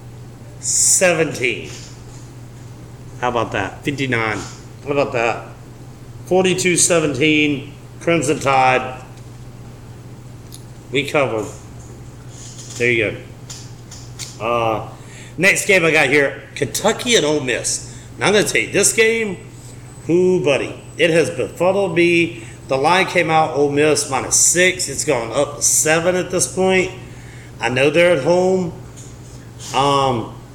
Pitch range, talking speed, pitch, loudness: 120-155 Hz, 120 wpm, 125 Hz, -16 LUFS